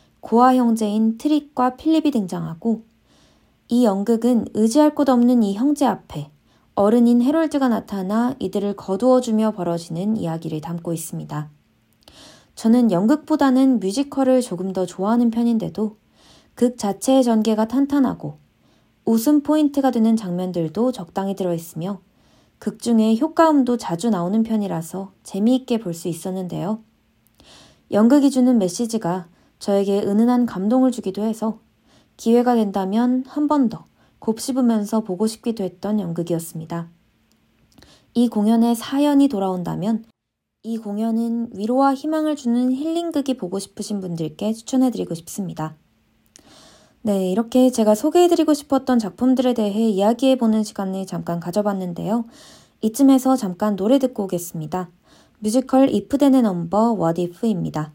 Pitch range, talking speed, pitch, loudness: 190-255 Hz, 325 characters per minute, 220 Hz, -20 LUFS